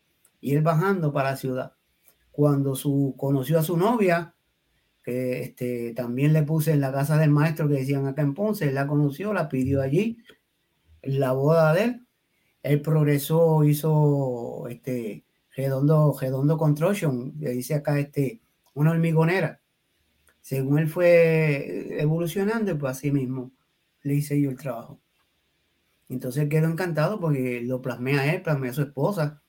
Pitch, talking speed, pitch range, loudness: 145 Hz, 150 wpm, 135-160 Hz, -24 LUFS